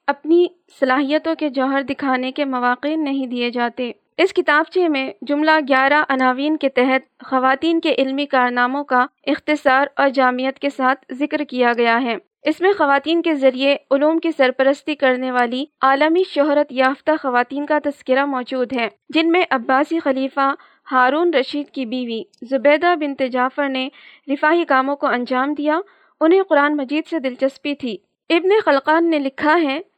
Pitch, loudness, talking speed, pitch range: 280 Hz, -18 LUFS, 155 wpm, 260-305 Hz